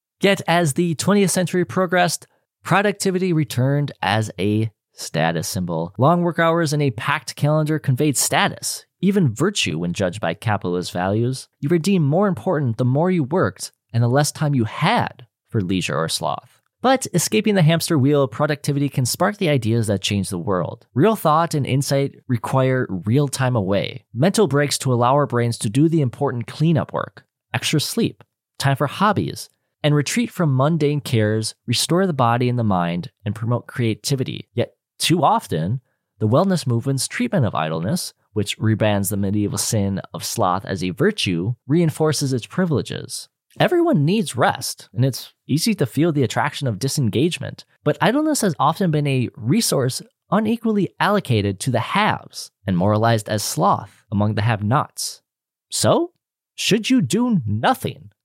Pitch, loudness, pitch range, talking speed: 135 Hz, -20 LUFS, 110-165 Hz, 165 wpm